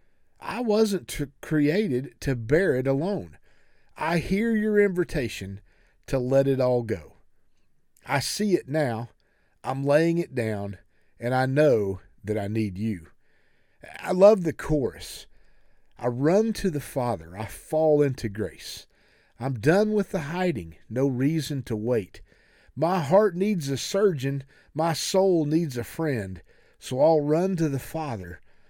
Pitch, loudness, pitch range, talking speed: 140 Hz, -25 LUFS, 115-170 Hz, 145 wpm